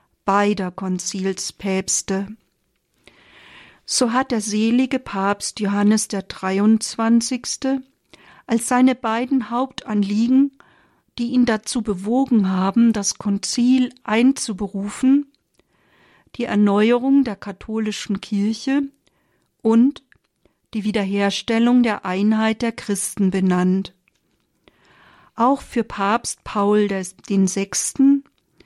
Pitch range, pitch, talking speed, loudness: 200-250 Hz, 220 Hz, 85 wpm, -20 LUFS